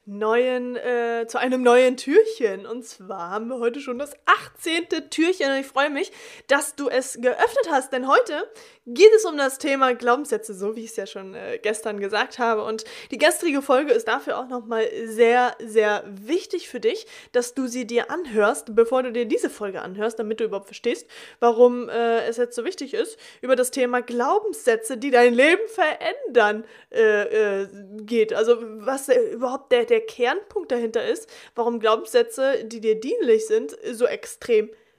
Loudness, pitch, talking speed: -22 LUFS, 255 Hz, 180 wpm